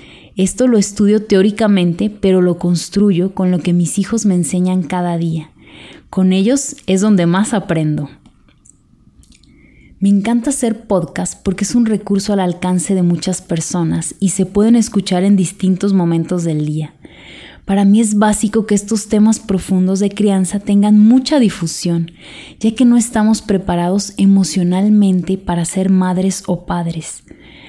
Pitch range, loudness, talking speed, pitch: 180-210 Hz, -14 LUFS, 145 wpm, 195 Hz